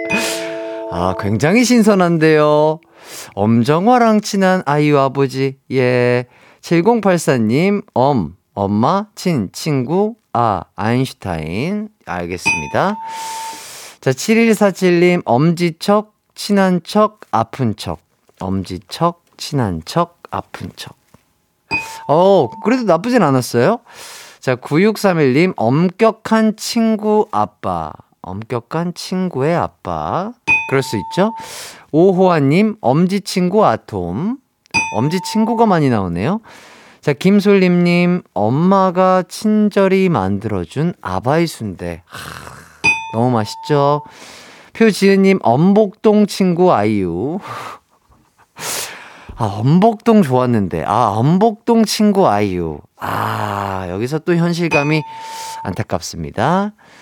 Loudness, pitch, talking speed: -15 LUFS, 170 Hz, 195 characters per minute